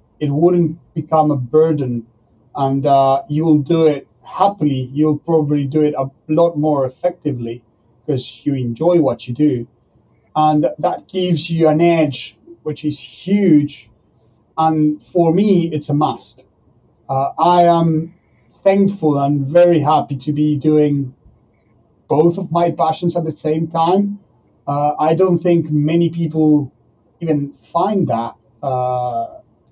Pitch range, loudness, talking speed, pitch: 135-165 Hz, -16 LUFS, 140 wpm, 150 Hz